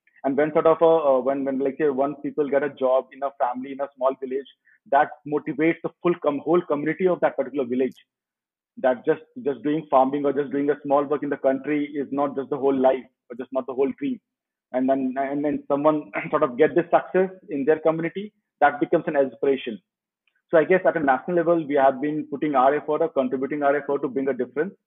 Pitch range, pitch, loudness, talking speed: 135-160 Hz, 145 Hz, -23 LUFS, 235 wpm